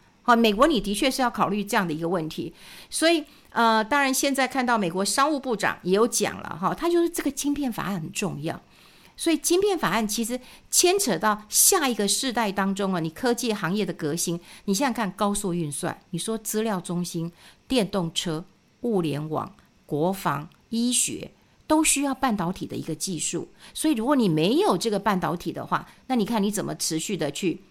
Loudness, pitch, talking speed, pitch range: -24 LUFS, 210 Hz, 295 characters per minute, 175-255 Hz